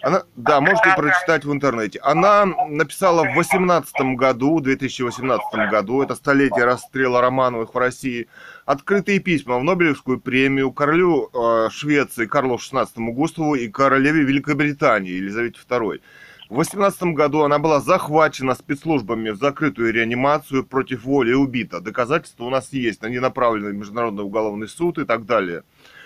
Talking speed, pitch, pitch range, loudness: 140 wpm, 135 Hz, 120-155 Hz, -19 LUFS